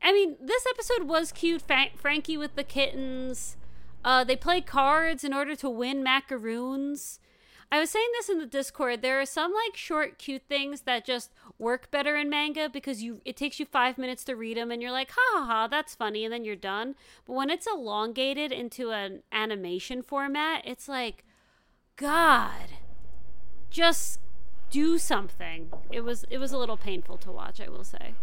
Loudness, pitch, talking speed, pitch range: -28 LUFS, 270 Hz, 180 wpm, 235-300 Hz